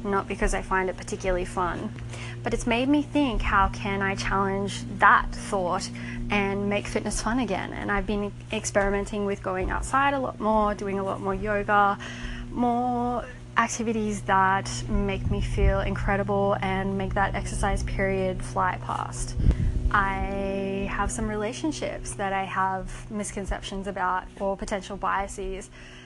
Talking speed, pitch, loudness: 145 wpm, 195 Hz, -27 LUFS